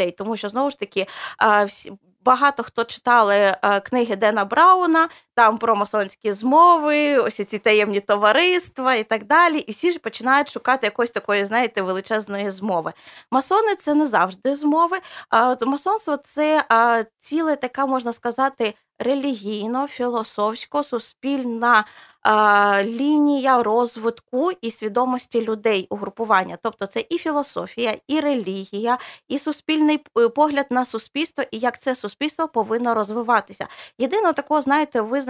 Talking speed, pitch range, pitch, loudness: 125 wpm, 215-290 Hz, 240 Hz, -20 LUFS